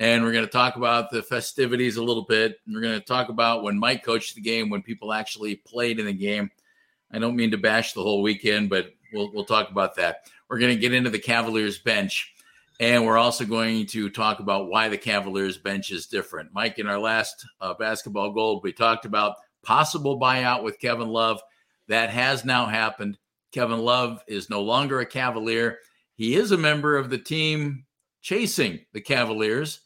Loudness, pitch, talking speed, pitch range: -24 LUFS, 115 Hz, 200 wpm, 110-125 Hz